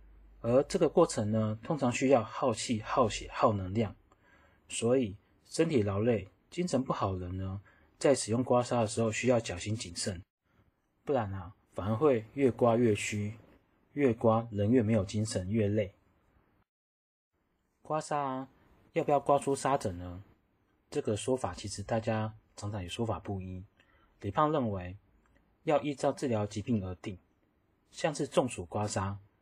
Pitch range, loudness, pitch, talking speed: 95-120 Hz, -32 LUFS, 110 Hz, 220 characters per minute